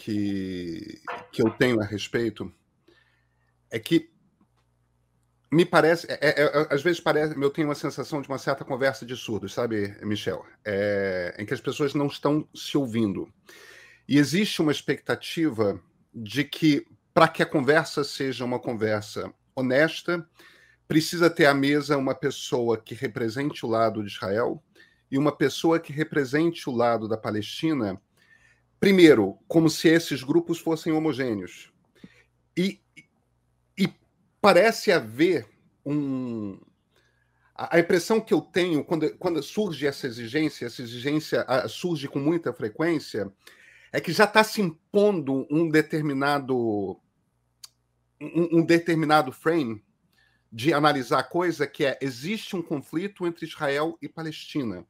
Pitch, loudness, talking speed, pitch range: 145 Hz, -25 LUFS, 135 wpm, 115-165 Hz